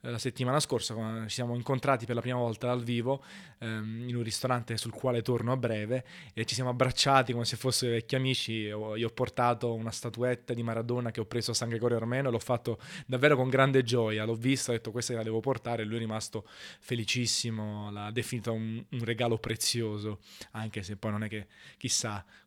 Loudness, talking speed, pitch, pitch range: -31 LUFS, 210 wpm, 120 Hz, 110-125 Hz